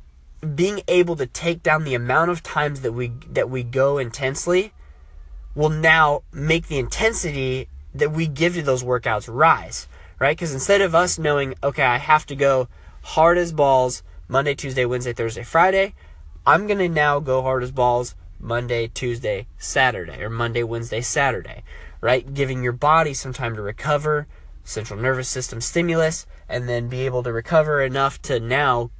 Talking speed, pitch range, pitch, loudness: 170 wpm, 120-155 Hz, 130 Hz, -21 LUFS